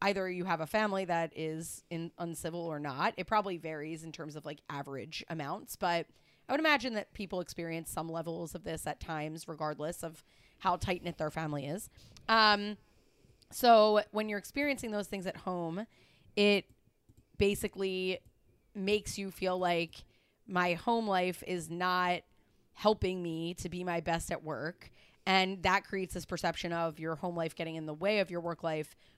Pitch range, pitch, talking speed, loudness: 160-195 Hz, 175 Hz, 175 wpm, -34 LUFS